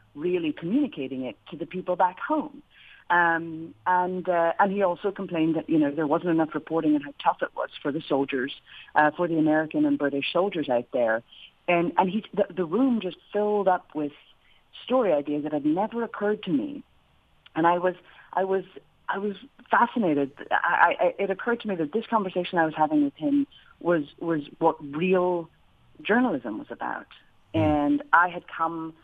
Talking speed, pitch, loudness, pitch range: 185 wpm, 175 Hz, -26 LUFS, 155-205 Hz